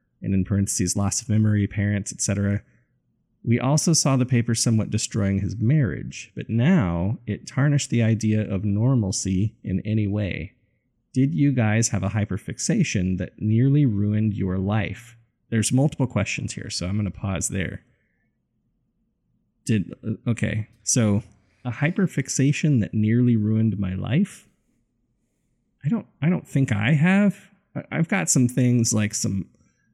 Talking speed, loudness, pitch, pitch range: 145 wpm, -23 LUFS, 110 Hz, 100-130 Hz